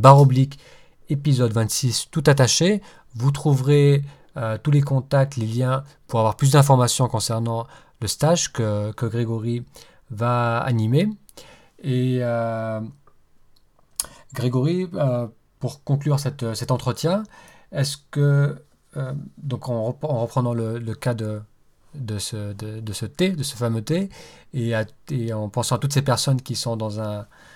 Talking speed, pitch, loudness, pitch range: 150 wpm, 125 Hz, -22 LUFS, 115-140 Hz